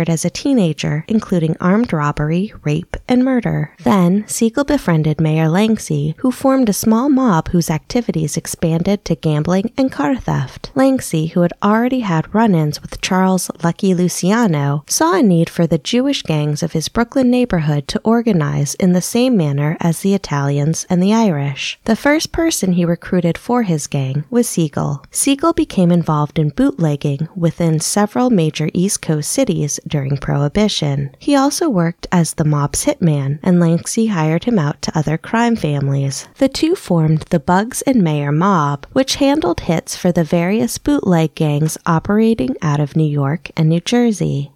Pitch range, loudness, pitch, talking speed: 155-225 Hz, -16 LUFS, 175 Hz, 165 wpm